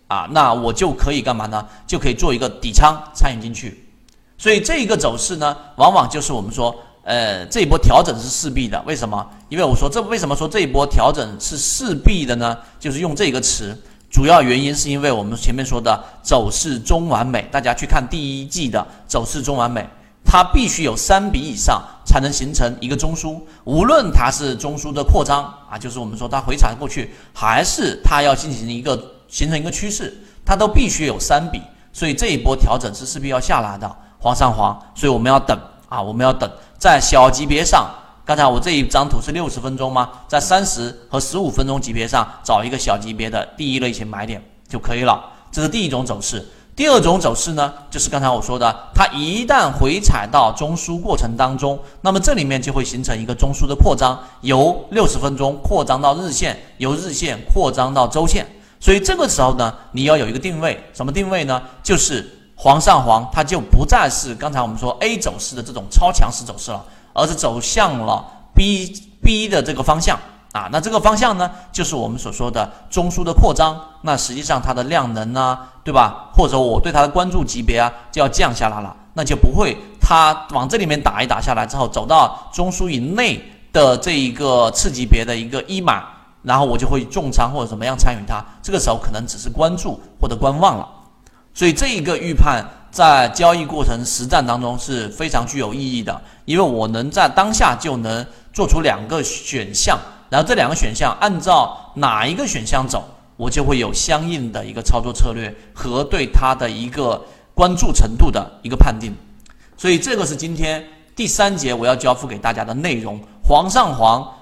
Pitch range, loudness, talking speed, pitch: 120-155 Hz, -17 LUFS, 305 characters per minute, 135 Hz